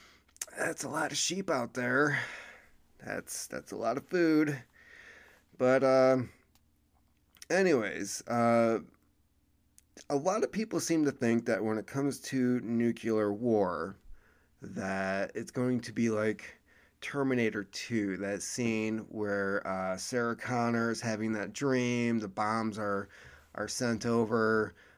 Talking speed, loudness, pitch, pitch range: 135 wpm, -31 LUFS, 115 Hz, 100-125 Hz